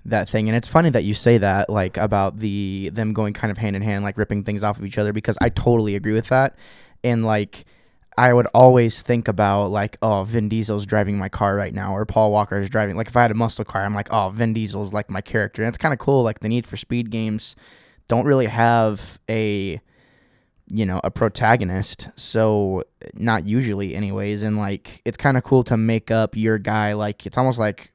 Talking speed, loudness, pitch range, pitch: 225 wpm, -20 LUFS, 100-115 Hz, 110 Hz